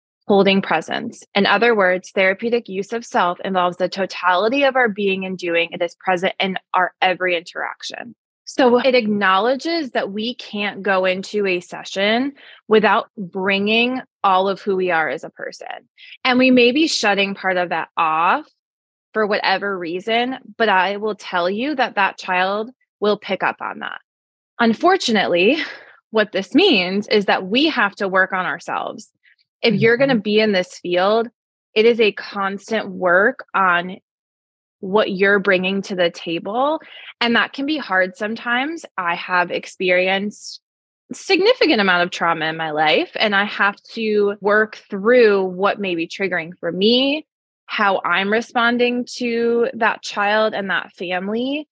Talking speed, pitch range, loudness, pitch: 160 wpm, 185-235 Hz, -18 LUFS, 205 Hz